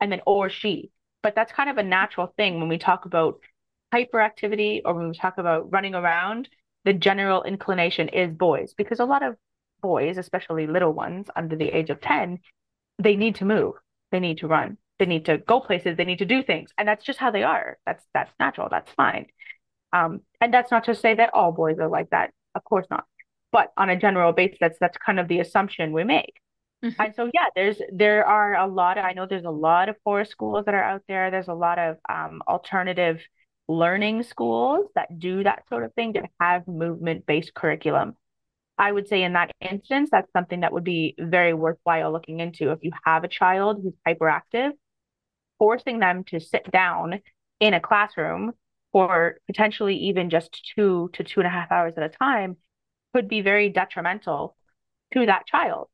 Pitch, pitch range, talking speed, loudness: 185 Hz, 170-210 Hz, 200 wpm, -23 LUFS